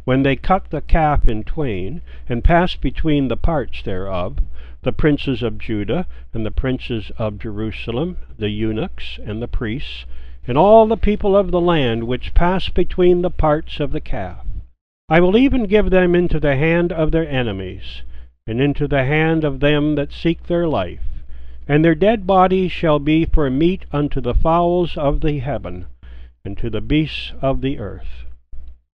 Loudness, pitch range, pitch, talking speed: -18 LUFS, 100-165 Hz, 140 Hz, 175 wpm